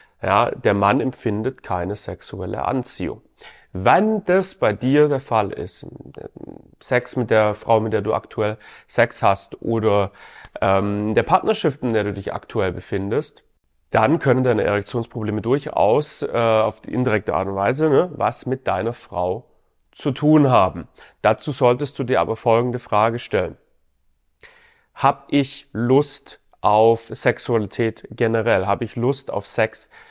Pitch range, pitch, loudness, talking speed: 105-130 Hz, 115 Hz, -20 LUFS, 140 wpm